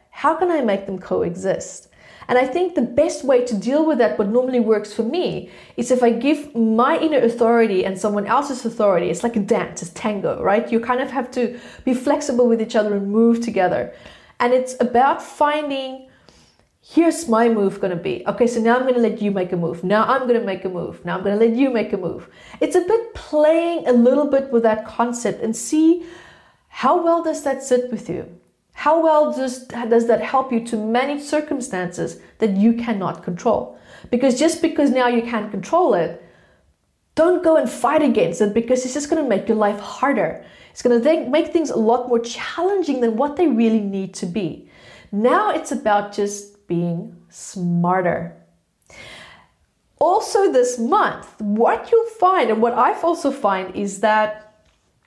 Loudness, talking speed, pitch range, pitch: -19 LUFS, 200 wpm, 210-285 Hz, 235 Hz